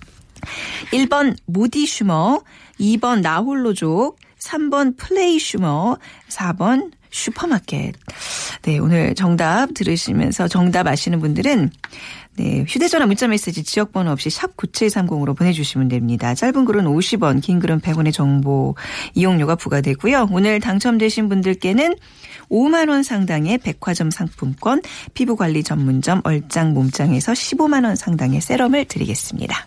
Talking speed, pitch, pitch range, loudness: 275 characters per minute, 190 Hz, 160-250 Hz, -18 LUFS